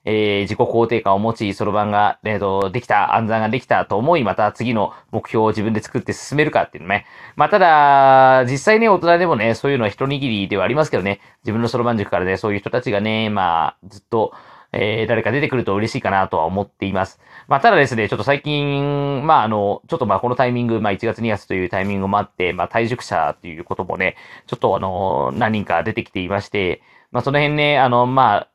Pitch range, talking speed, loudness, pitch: 100-130 Hz, 455 characters per minute, -18 LUFS, 110 Hz